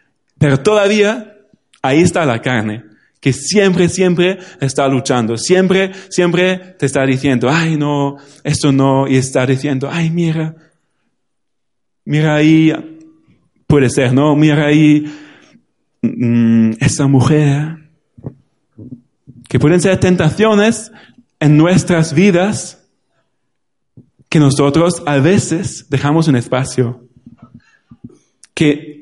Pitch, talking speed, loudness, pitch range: 150 Hz, 105 wpm, -13 LUFS, 135-175 Hz